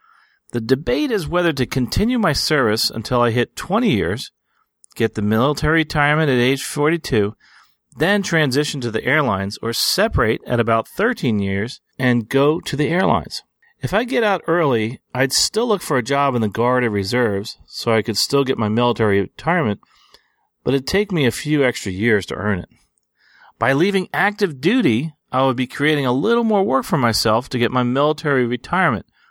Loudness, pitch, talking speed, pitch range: -18 LUFS, 135 Hz, 185 wpm, 115-160 Hz